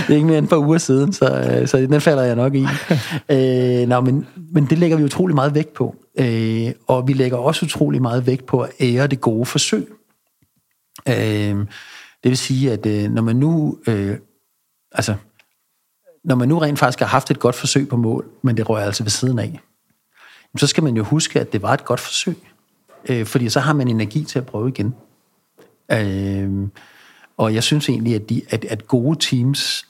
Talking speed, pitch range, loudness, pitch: 200 wpm, 115-145 Hz, -18 LUFS, 130 Hz